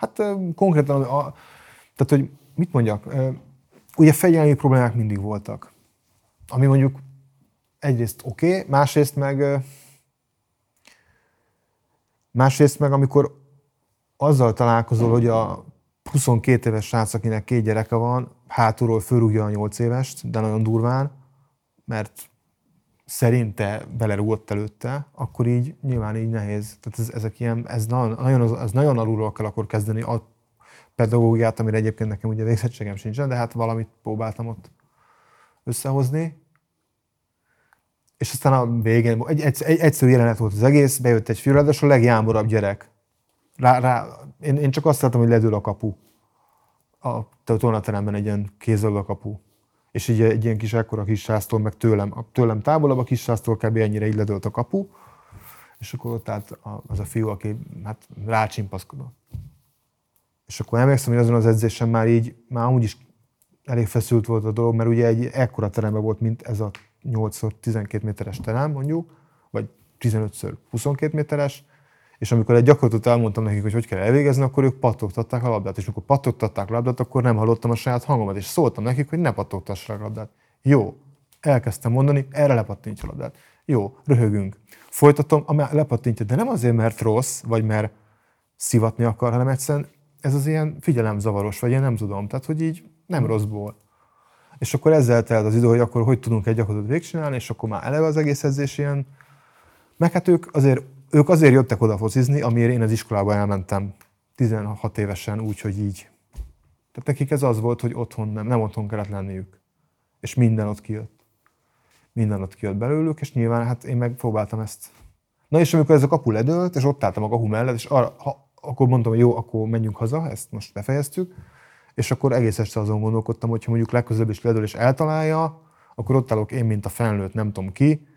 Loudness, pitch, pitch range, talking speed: -21 LUFS, 115 Hz, 110-135 Hz, 170 wpm